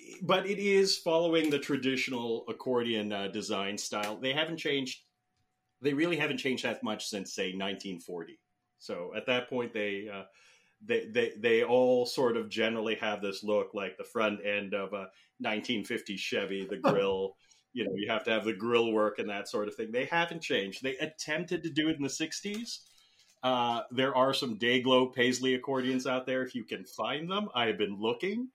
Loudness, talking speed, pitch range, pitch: -31 LUFS, 190 wpm, 110-160 Hz, 130 Hz